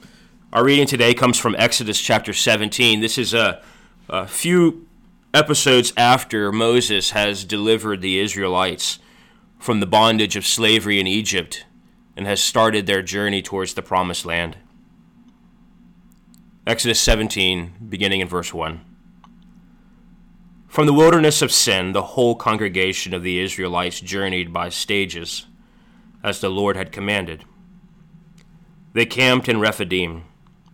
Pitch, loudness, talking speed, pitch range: 105 Hz, -18 LUFS, 125 wpm, 95-125 Hz